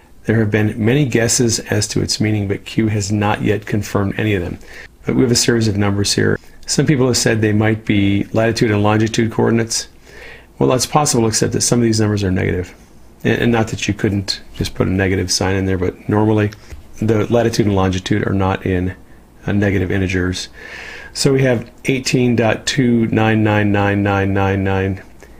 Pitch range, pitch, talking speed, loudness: 100-115 Hz, 105 Hz, 175 wpm, -16 LUFS